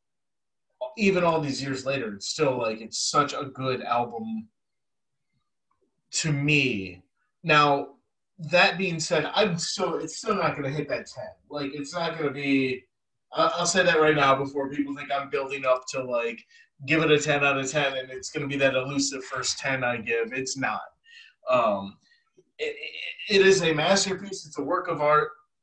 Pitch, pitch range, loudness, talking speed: 145 Hz, 135-185 Hz, -25 LUFS, 180 wpm